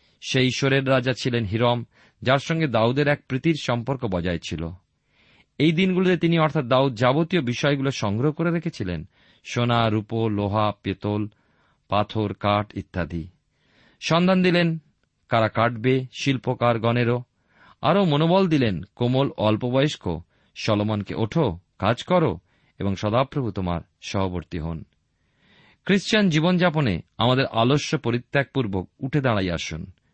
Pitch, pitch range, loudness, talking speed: 120 Hz, 100-145 Hz, -23 LUFS, 115 wpm